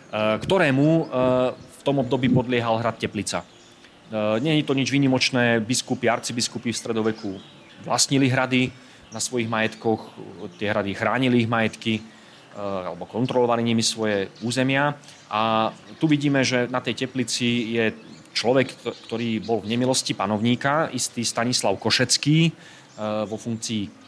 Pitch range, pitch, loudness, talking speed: 110-130 Hz, 120 Hz, -23 LUFS, 125 wpm